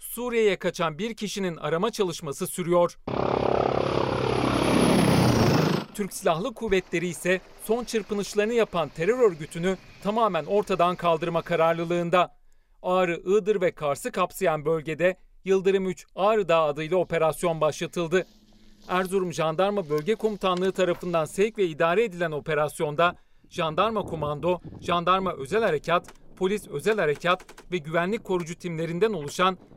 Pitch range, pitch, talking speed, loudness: 165-195 Hz, 180 Hz, 115 wpm, -25 LUFS